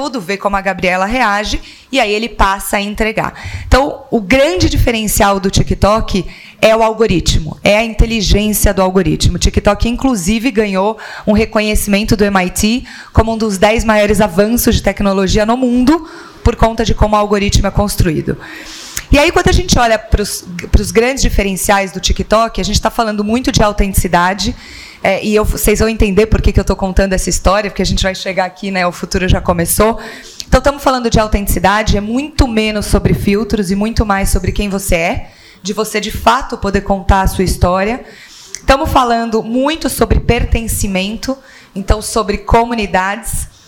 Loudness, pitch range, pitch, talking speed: -13 LUFS, 195-230 Hz, 215 Hz, 175 wpm